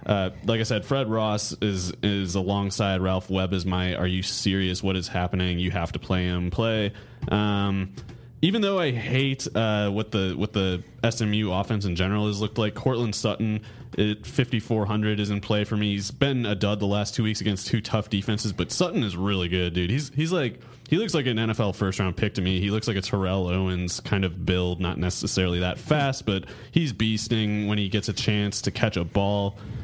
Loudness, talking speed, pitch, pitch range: -26 LUFS, 220 wpm, 105 Hz, 95-115 Hz